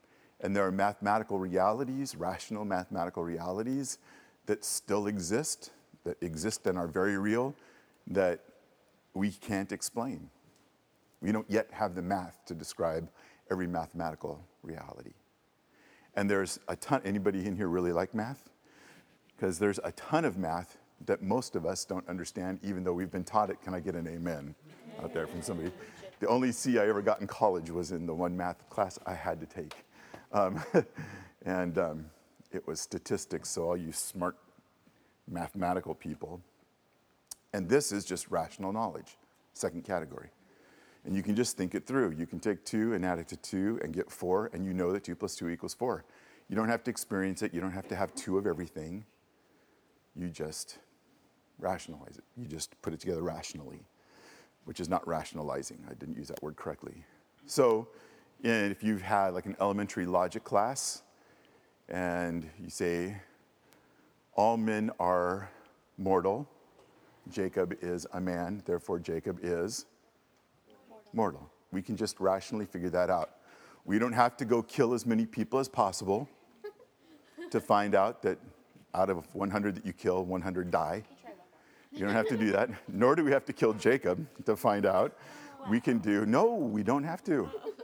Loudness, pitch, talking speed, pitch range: -33 LUFS, 95 Hz, 170 wpm, 90-110 Hz